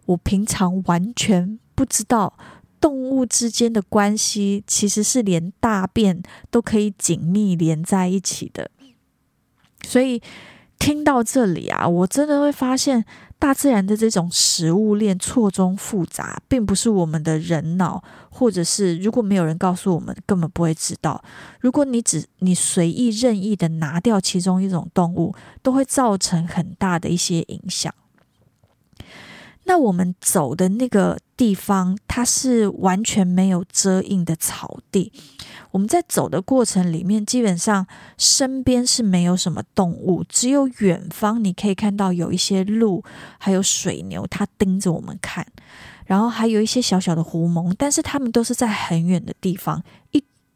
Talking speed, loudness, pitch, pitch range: 235 characters per minute, -19 LUFS, 195 Hz, 180-235 Hz